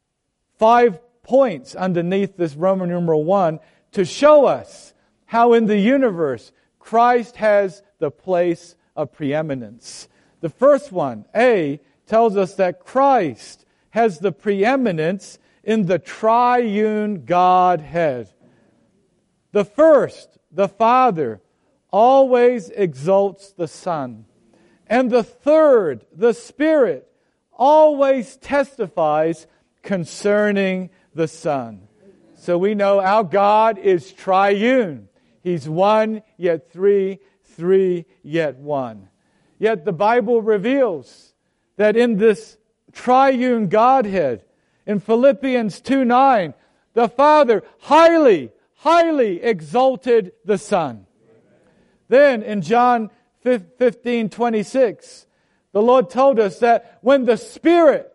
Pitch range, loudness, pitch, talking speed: 180-245 Hz, -17 LUFS, 210 Hz, 105 wpm